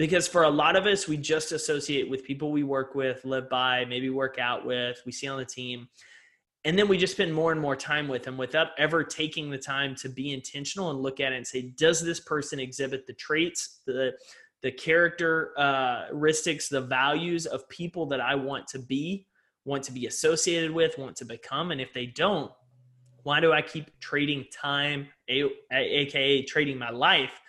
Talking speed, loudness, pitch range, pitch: 200 wpm, -27 LUFS, 130-160 Hz, 145 Hz